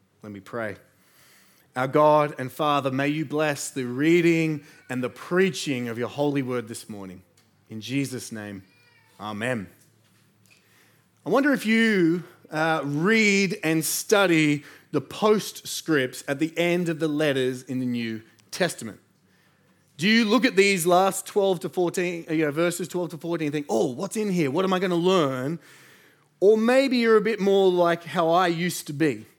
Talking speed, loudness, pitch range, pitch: 170 wpm, -23 LUFS, 130-180 Hz, 155 Hz